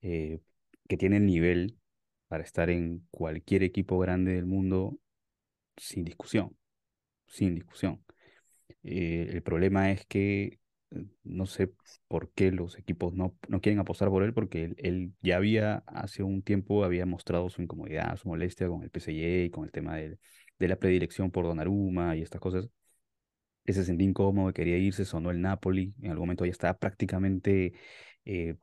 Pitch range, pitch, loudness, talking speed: 90-100 Hz, 95 Hz, -31 LUFS, 170 wpm